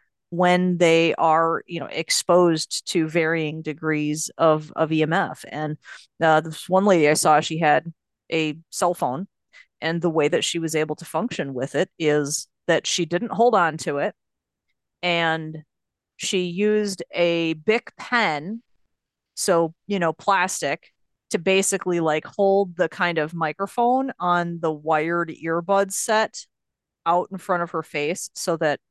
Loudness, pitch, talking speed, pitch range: -22 LUFS, 165 Hz, 155 wpm, 155-185 Hz